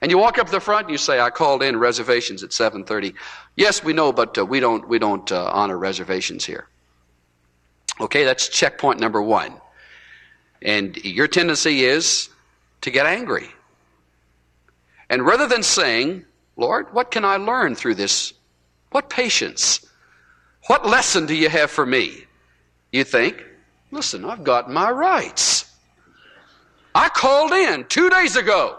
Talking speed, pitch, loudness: 150 wpm, 150 Hz, -18 LUFS